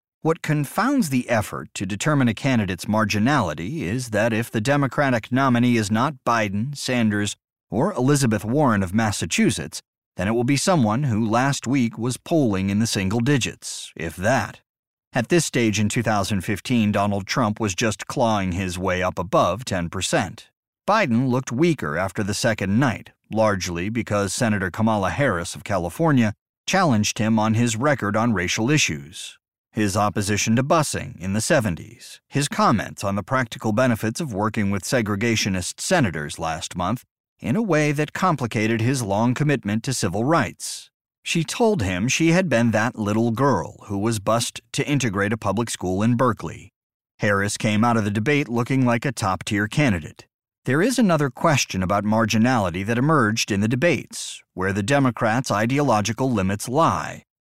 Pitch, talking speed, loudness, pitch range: 115 Hz, 165 wpm, -22 LUFS, 105-130 Hz